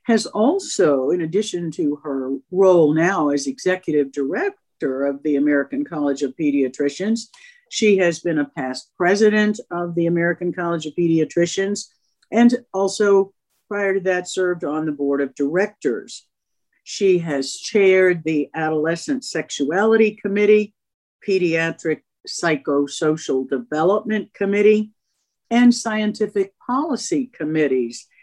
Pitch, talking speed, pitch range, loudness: 180 Hz, 115 wpm, 150-210 Hz, -20 LUFS